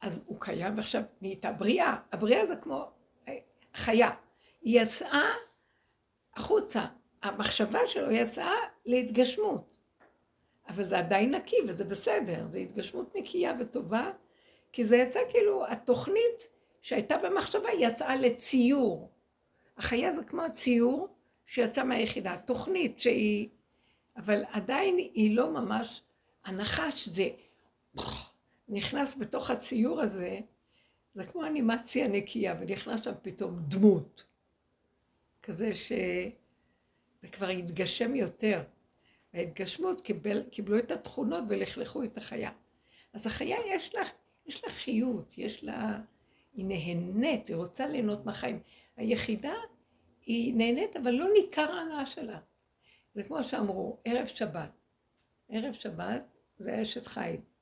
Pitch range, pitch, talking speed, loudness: 210-290 Hz, 240 Hz, 115 wpm, -31 LUFS